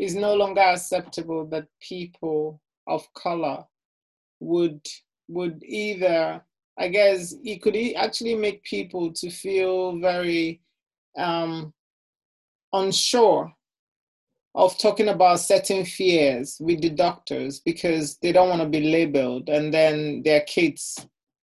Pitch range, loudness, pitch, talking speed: 160-195 Hz, -23 LUFS, 175 Hz, 120 wpm